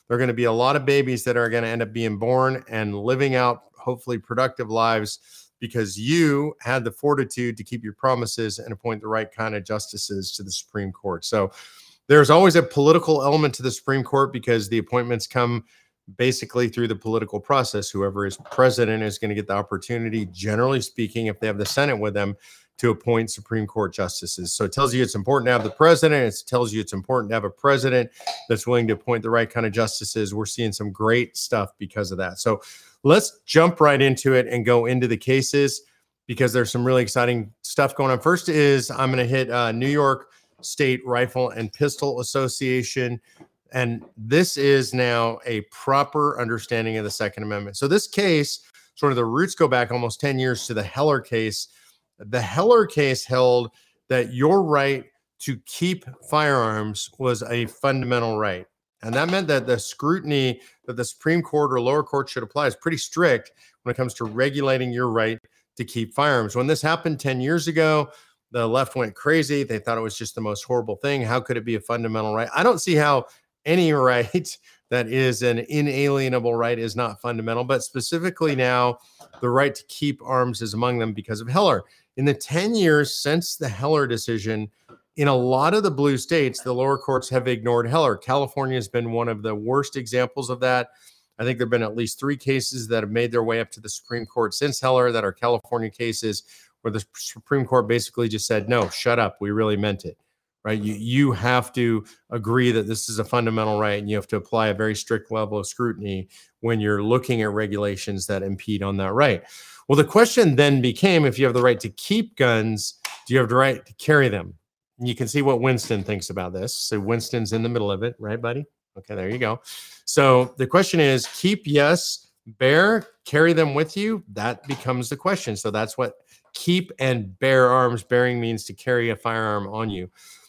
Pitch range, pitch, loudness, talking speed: 110-135 Hz, 120 Hz, -22 LUFS, 210 wpm